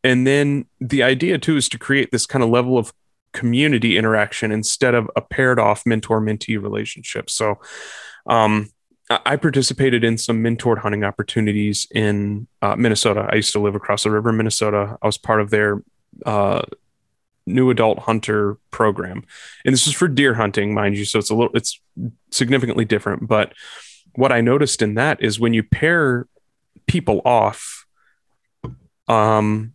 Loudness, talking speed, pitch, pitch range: -18 LUFS, 165 wpm, 110 Hz, 105-125 Hz